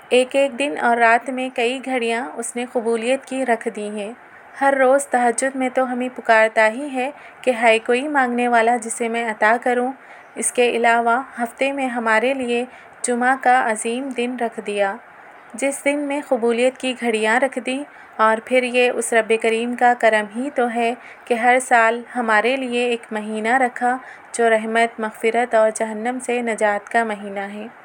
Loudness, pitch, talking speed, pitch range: -19 LUFS, 240 Hz, 180 wpm, 225-255 Hz